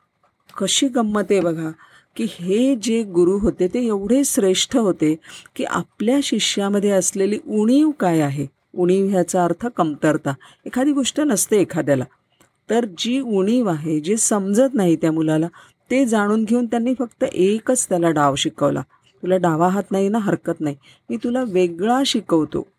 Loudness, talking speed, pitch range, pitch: -19 LUFS, 145 wpm, 170-240 Hz, 200 Hz